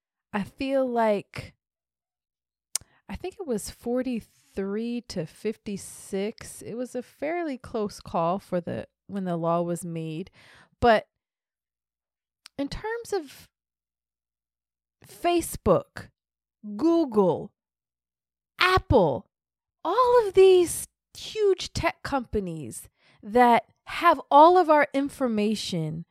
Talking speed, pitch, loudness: 95 wpm, 220 Hz, -25 LUFS